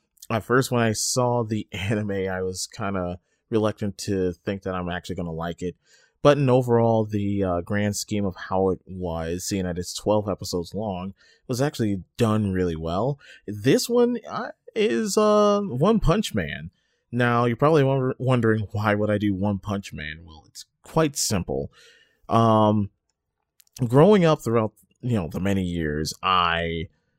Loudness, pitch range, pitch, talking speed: -24 LUFS, 90-120 Hz, 105 Hz, 165 wpm